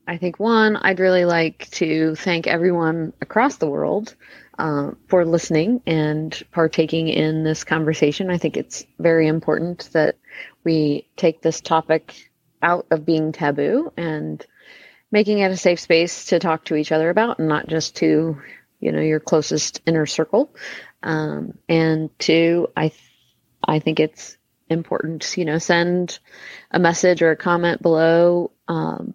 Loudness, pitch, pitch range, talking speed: -20 LUFS, 165 Hz, 155-175 Hz, 155 wpm